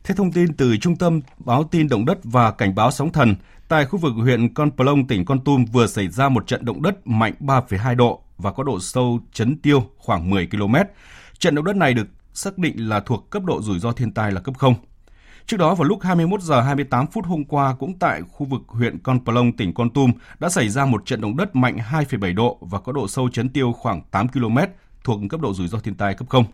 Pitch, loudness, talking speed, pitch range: 125 Hz, -20 LUFS, 245 wpm, 115-145 Hz